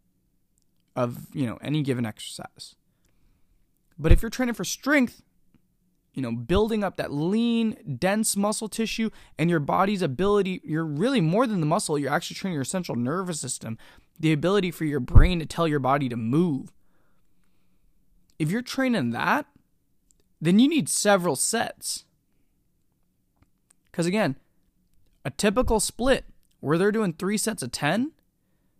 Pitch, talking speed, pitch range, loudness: 180 Hz, 145 wpm, 145-220 Hz, -25 LUFS